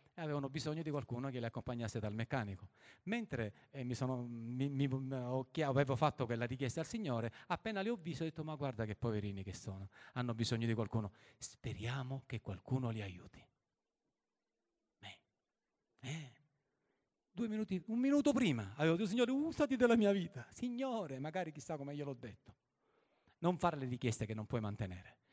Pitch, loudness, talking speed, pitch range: 135 Hz, -40 LUFS, 170 wpm, 115-165 Hz